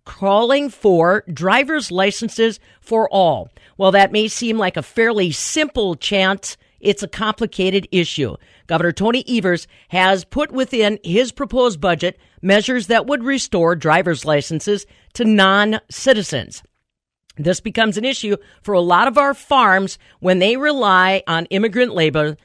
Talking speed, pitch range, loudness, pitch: 140 wpm, 180-230 Hz, -17 LUFS, 200 Hz